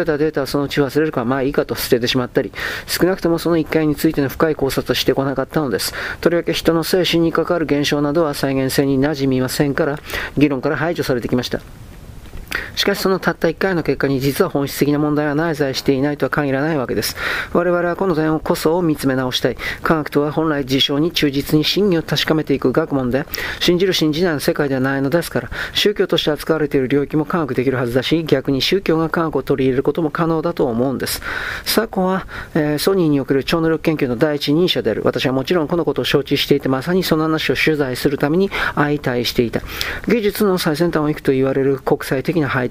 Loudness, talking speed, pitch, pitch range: -18 LUFS, 460 characters per minute, 150 Hz, 135-165 Hz